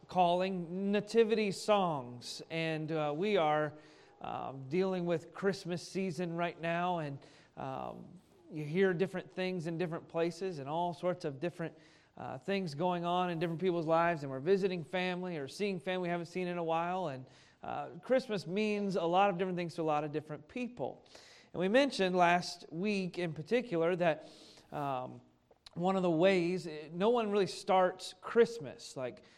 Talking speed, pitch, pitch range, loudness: 170 wpm, 175 Hz, 160-190 Hz, -34 LUFS